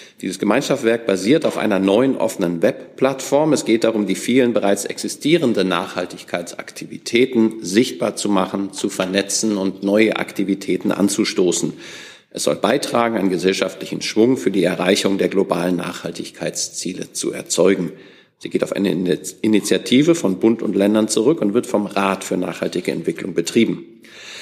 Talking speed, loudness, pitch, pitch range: 140 wpm, -19 LUFS, 100 Hz, 95-115 Hz